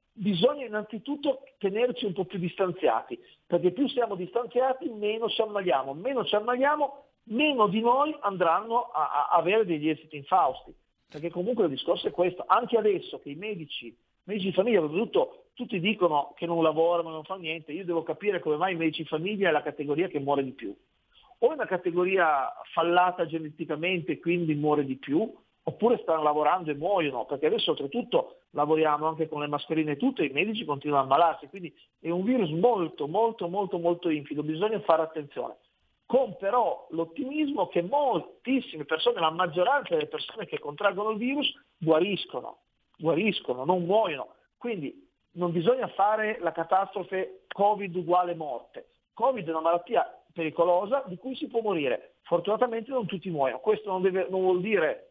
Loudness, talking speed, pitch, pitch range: -28 LUFS, 170 wpm, 185 Hz, 165-240 Hz